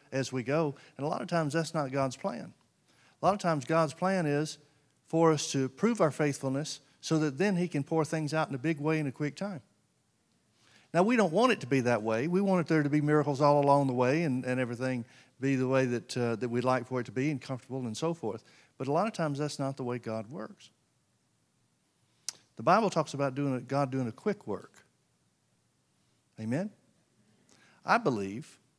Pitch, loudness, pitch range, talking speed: 145 Hz, -30 LUFS, 130-160 Hz, 220 wpm